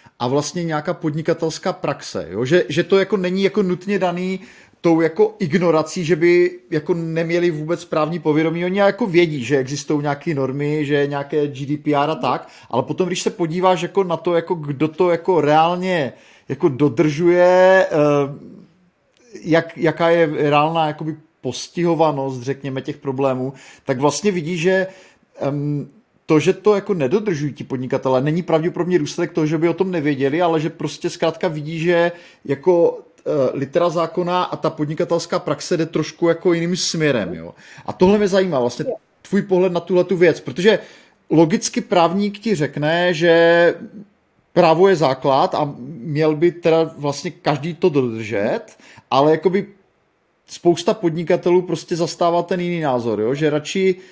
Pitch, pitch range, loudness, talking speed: 170 Hz, 150-180 Hz, -18 LUFS, 155 wpm